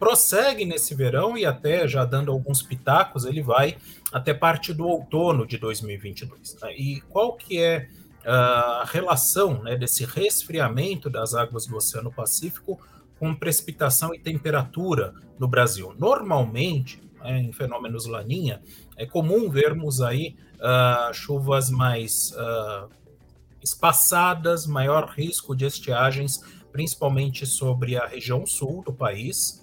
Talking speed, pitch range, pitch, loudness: 130 wpm, 125-160 Hz, 135 Hz, -23 LUFS